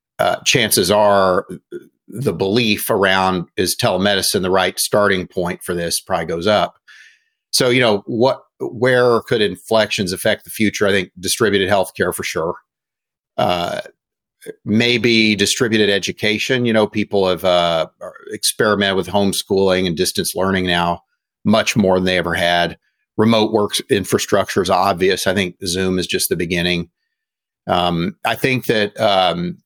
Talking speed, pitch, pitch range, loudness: 145 wpm, 100 Hz, 90-110 Hz, -17 LUFS